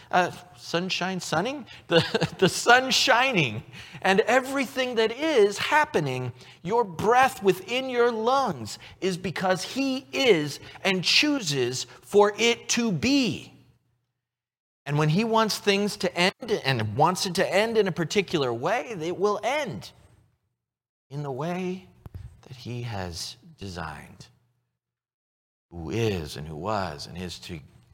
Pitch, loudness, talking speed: 175 Hz, -24 LUFS, 130 wpm